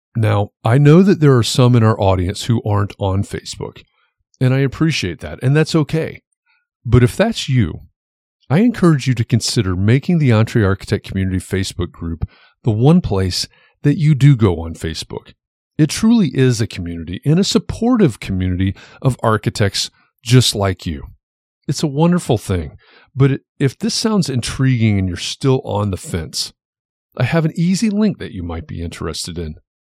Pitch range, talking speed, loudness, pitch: 95-150 Hz, 175 wpm, -16 LUFS, 120 Hz